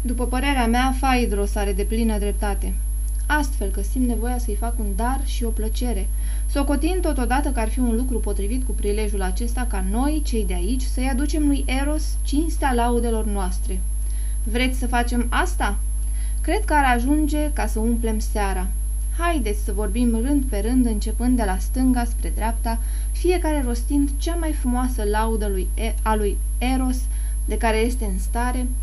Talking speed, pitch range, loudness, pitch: 170 wpm, 215-265 Hz, -23 LUFS, 240 Hz